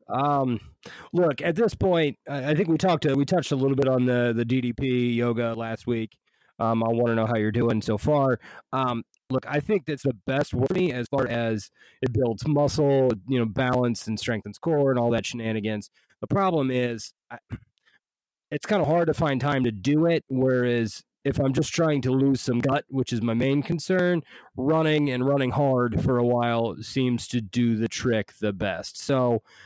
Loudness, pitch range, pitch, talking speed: -25 LUFS, 120-145 Hz, 130 Hz, 205 wpm